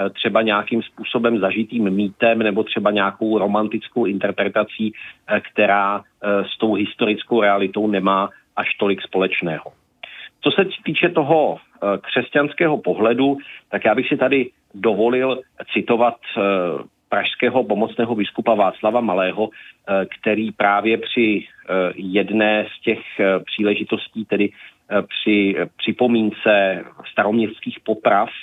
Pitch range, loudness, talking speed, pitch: 100-115 Hz, -19 LUFS, 105 wpm, 105 Hz